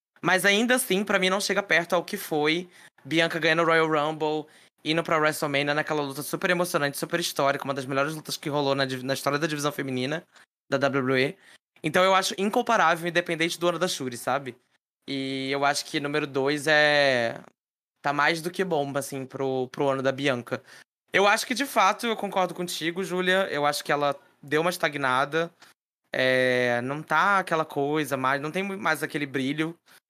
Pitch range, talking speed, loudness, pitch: 140-175 Hz, 185 wpm, -25 LUFS, 155 Hz